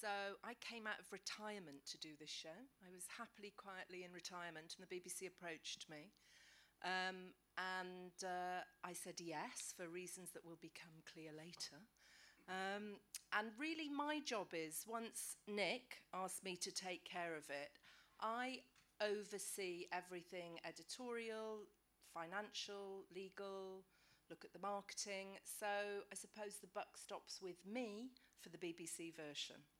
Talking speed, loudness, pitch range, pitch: 145 wpm, -50 LUFS, 170-205 Hz, 185 Hz